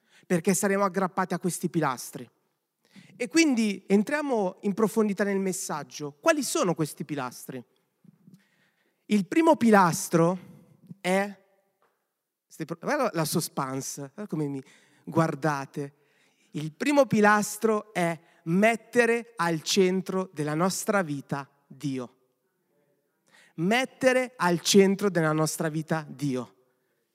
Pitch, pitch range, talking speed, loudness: 180 Hz, 155-205 Hz, 100 wpm, -26 LUFS